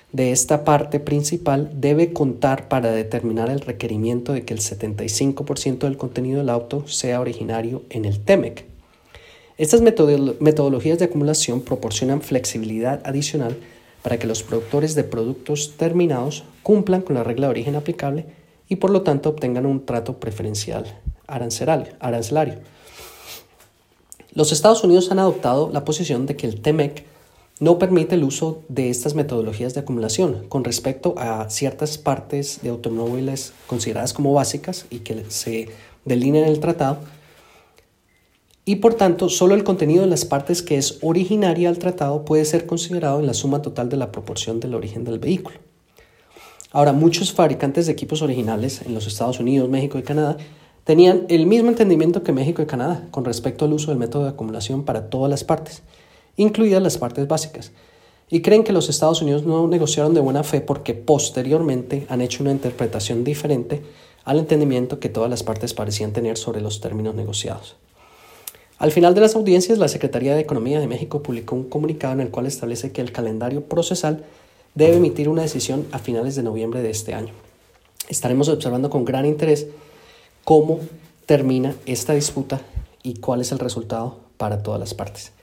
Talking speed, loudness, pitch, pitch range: 165 wpm, -20 LUFS, 140 Hz, 120-155 Hz